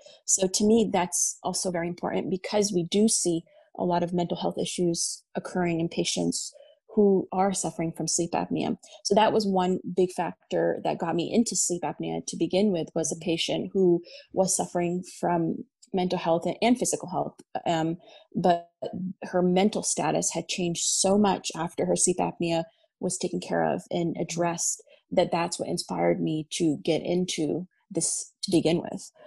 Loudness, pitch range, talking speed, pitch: -27 LUFS, 170-195 Hz, 170 wpm, 180 Hz